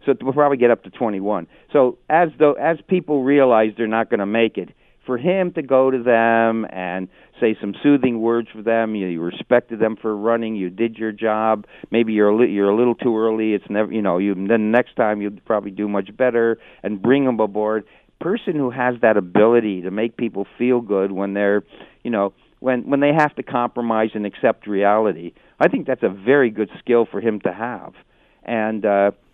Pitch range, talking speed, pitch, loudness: 105-125 Hz, 215 wpm, 115 Hz, -19 LUFS